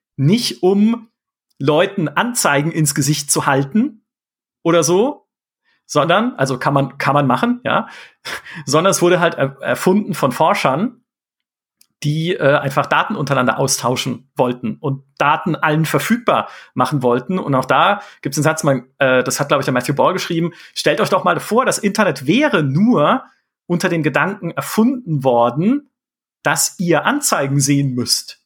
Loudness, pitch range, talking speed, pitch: -16 LUFS, 135-195 Hz, 155 wpm, 155 Hz